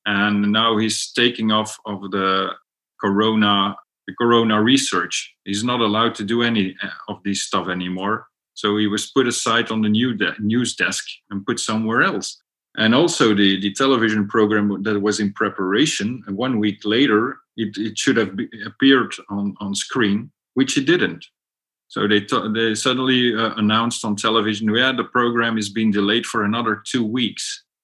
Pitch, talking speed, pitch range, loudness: 110 Hz, 160 wpm, 105-115 Hz, -19 LUFS